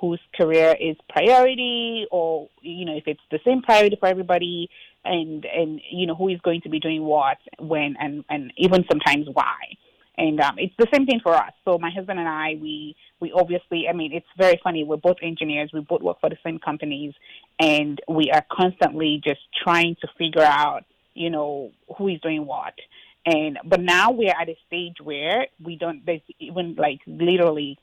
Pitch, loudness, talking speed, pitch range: 165 Hz, -22 LUFS, 200 wpm, 155-180 Hz